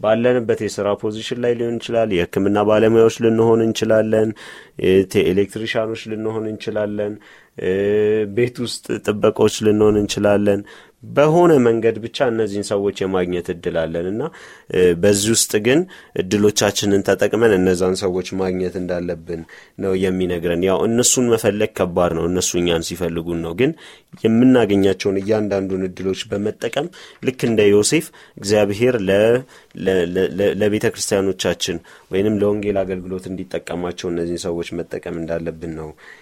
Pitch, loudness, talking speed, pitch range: 100 Hz, -18 LUFS, 110 wpm, 95-110 Hz